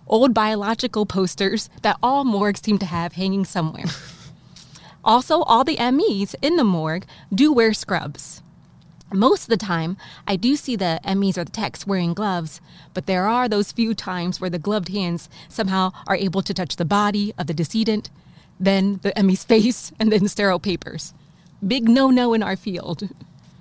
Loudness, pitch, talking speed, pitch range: -21 LUFS, 195 Hz, 180 wpm, 170-215 Hz